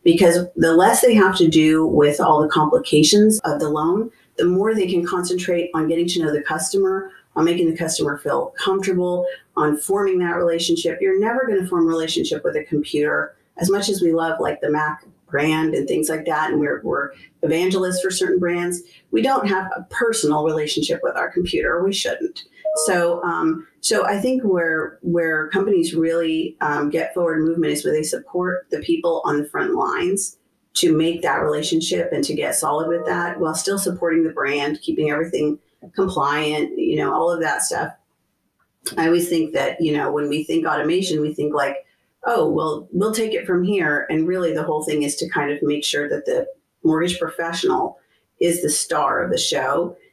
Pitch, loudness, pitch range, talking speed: 170 Hz, -20 LUFS, 155-195 Hz, 195 wpm